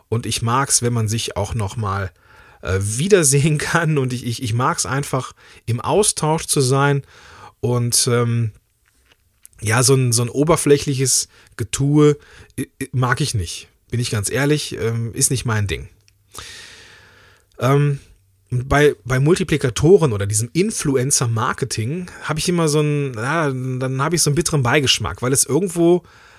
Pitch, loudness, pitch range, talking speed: 130 Hz, -18 LUFS, 110-145 Hz, 150 wpm